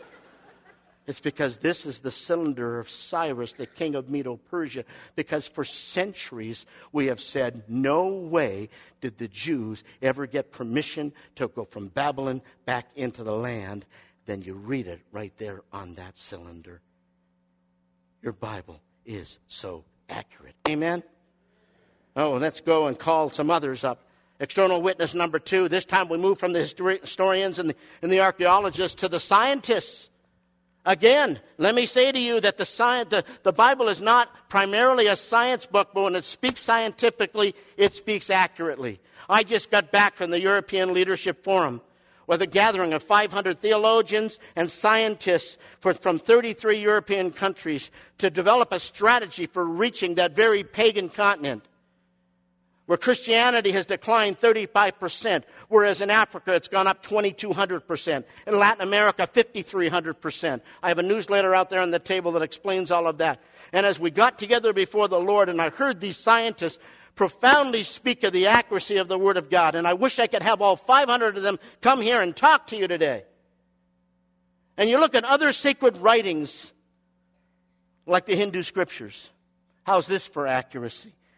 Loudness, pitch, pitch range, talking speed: -23 LUFS, 180 Hz, 145-205 Hz, 160 wpm